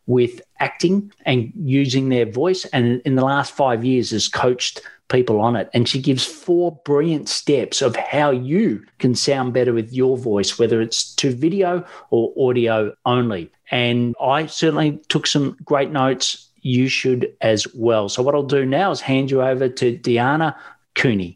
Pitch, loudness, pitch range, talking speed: 130 Hz, -19 LUFS, 120-145 Hz, 175 wpm